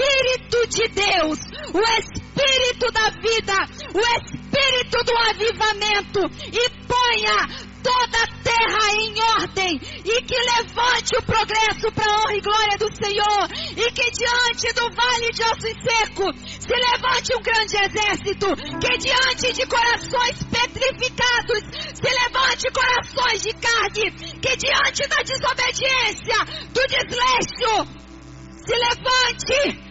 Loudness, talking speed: -19 LUFS, 120 wpm